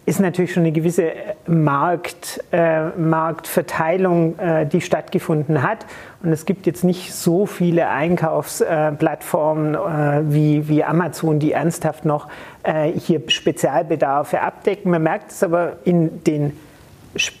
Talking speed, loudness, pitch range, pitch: 130 wpm, -19 LUFS, 155-175 Hz, 165 Hz